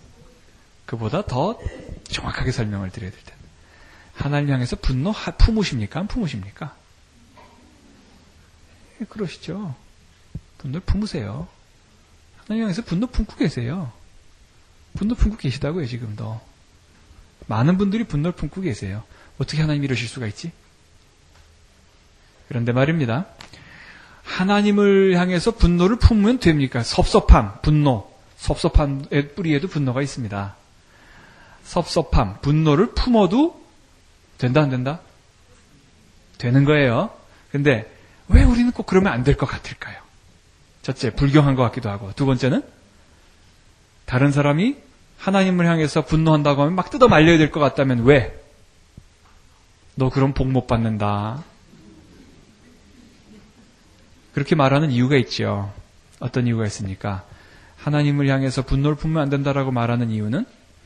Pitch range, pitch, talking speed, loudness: 100-155 Hz, 130 Hz, 270 characters per minute, -20 LUFS